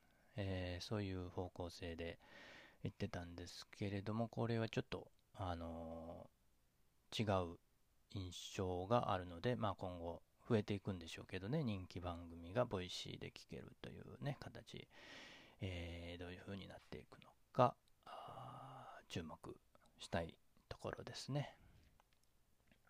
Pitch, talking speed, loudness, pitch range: 95 Hz, 270 characters per minute, -46 LUFS, 85-110 Hz